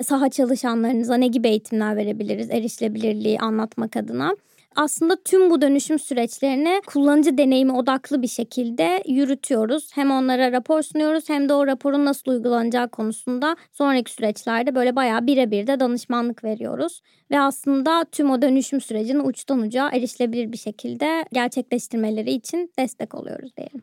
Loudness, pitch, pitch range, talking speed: -21 LUFS, 260 Hz, 235-285 Hz, 140 wpm